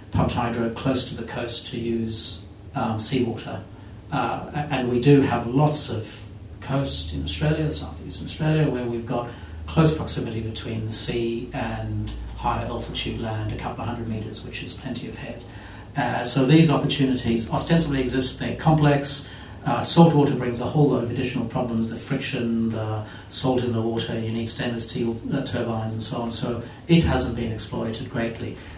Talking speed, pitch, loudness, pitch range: 180 wpm, 120 Hz, -24 LUFS, 110-130 Hz